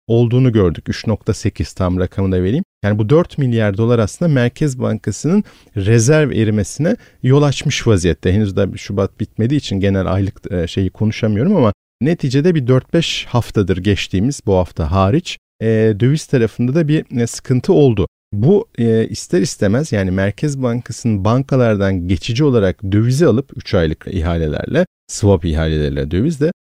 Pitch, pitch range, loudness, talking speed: 110 Hz, 95-130 Hz, -16 LUFS, 135 wpm